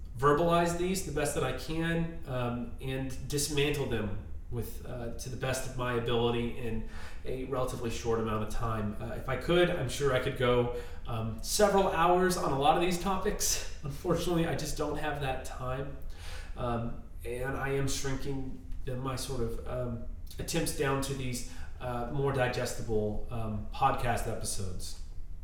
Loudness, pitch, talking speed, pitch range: -32 LUFS, 125 Hz, 165 wpm, 115-140 Hz